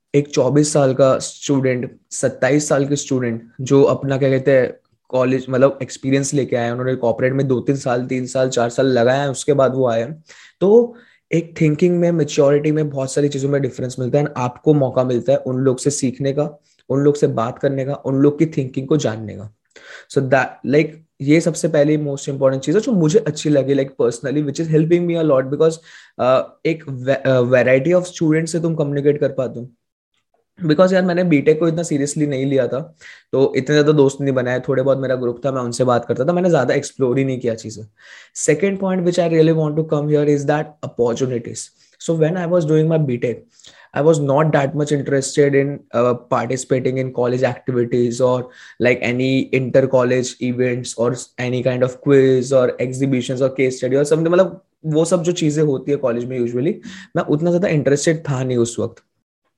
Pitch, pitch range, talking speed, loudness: 135 Hz, 130-155 Hz, 175 wpm, -18 LUFS